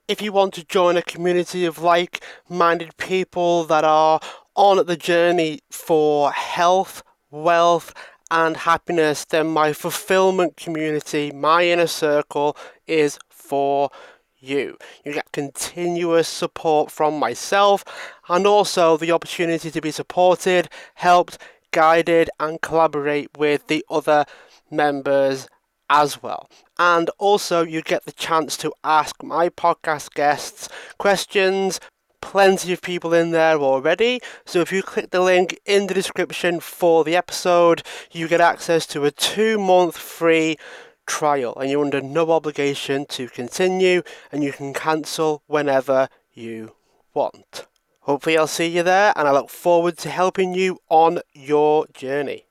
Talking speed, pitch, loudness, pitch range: 140 wpm, 165 Hz, -19 LUFS, 150-175 Hz